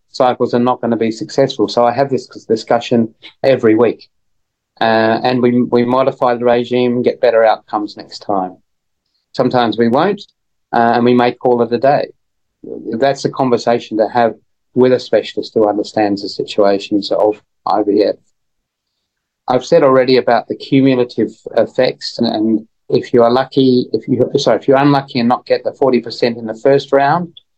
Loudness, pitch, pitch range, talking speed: -14 LUFS, 120 Hz, 115-130 Hz, 175 wpm